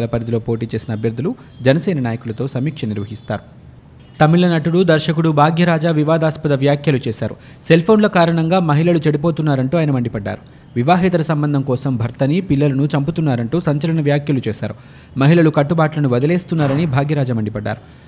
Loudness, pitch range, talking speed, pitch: -16 LUFS, 125-165 Hz, 115 wpm, 145 Hz